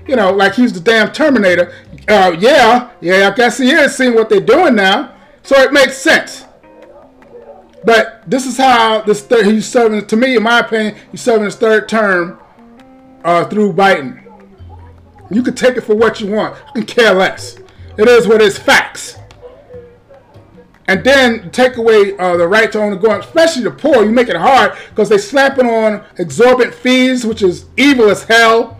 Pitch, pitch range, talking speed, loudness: 225 Hz, 200-255 Hz, 190 wpm, -11 LUFS